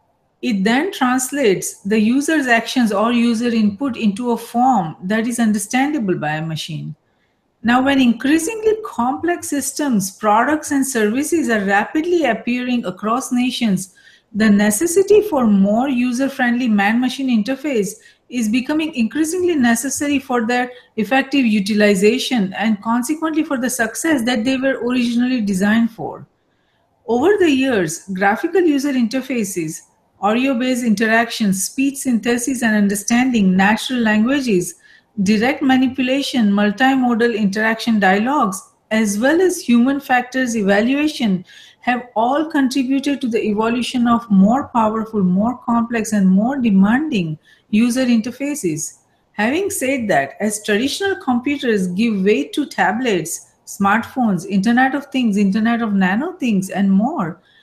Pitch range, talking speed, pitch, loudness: 210-265 Hz, 125 wpm, 235 Hz, -17 LUFS